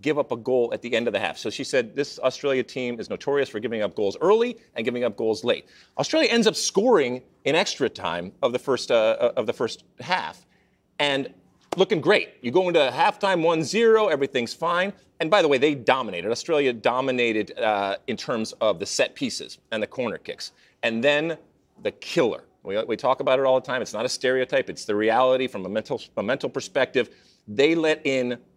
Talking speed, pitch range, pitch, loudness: 210 wpm, 125-185 Hz, 140 Hz, -24 LUFS